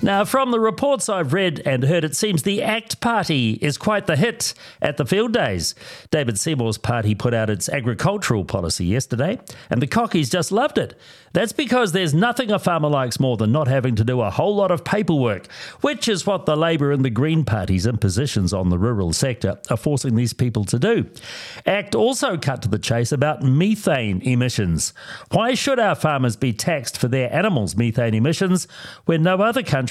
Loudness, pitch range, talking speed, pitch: -20 LUFS, 120-195 Hz, 195 wpm, 150 Hz